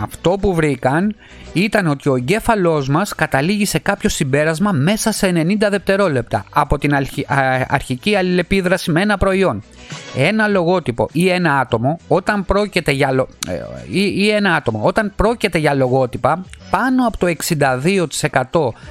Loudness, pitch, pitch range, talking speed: -16 LUFS, 170 Hz, 140-200 Hz, 135 wpm